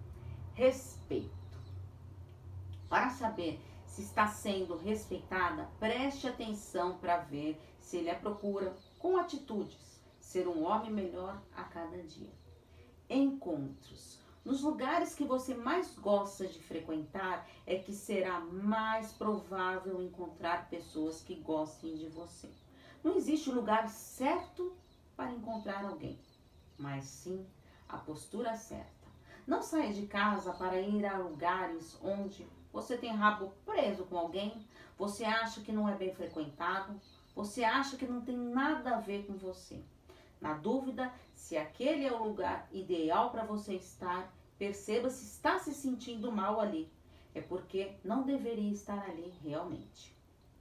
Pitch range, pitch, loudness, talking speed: 170-225 Hz, 195 Hz, -37 LUFS, 135 wpm